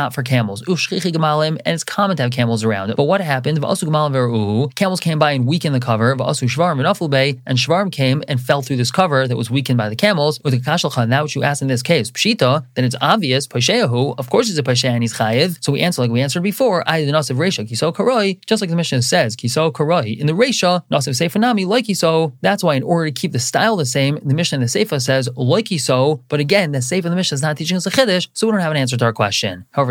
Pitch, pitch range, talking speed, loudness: 150 Hz, 125-175 Hz, 210 wpm, -17 LUFS